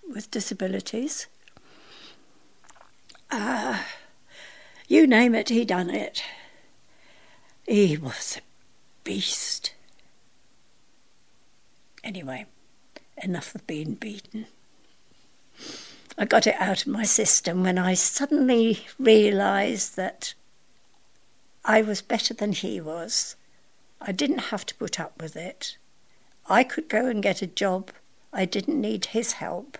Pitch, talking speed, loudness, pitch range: 215 Hz, 115 wpm, -24 LUFS, 190-235 Hz